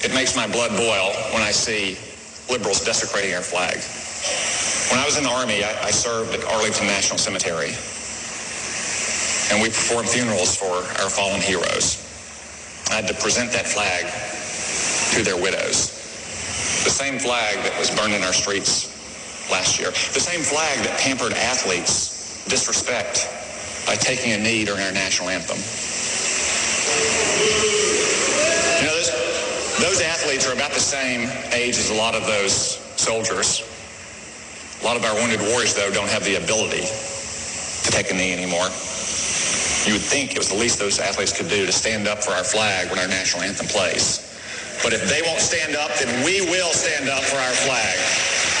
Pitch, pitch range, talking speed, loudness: 105 Hz, 95-120 Hz, 165 wpm, -20 LUFS